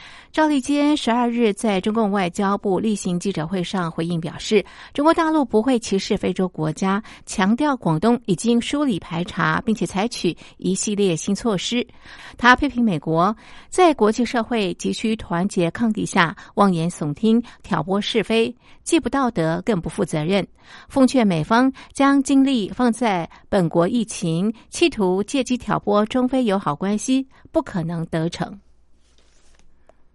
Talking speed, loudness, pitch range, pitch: 235 characters per minute, -20 LUFS, 175-240 Hz, 210 Hz